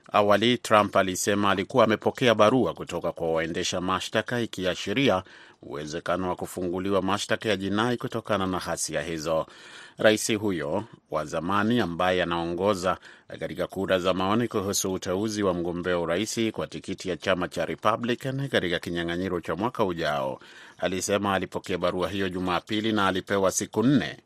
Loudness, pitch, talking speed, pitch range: -26 LUFS, 95 Hz, 140 wpm, 90-105 Hz